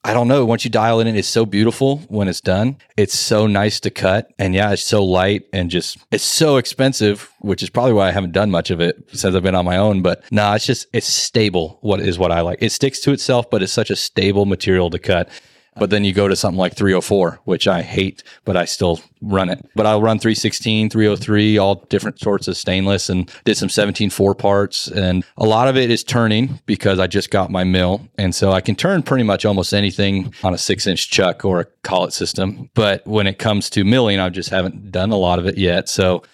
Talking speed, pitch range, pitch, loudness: 245 wpm, 95-110 Hz, 100 Hz, -17 LUFS